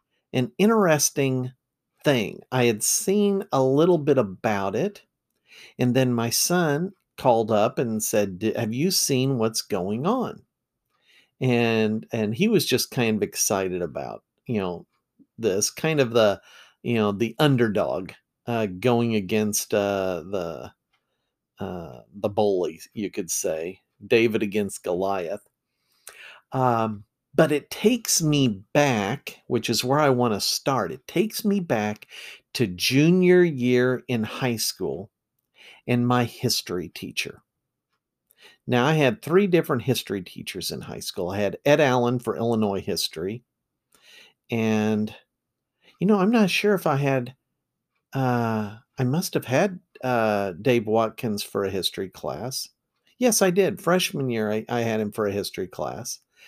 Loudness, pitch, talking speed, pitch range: -24 LUFS, 125 Hz, 145 wpm, 110-150 Hz